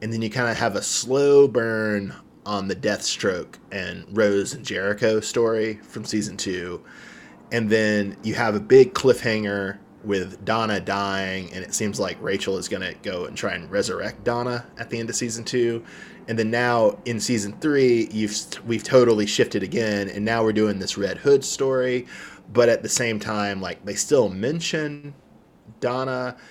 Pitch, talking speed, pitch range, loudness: 110 Hz, 180 wpm, 105-120 Hz, -23 LUFS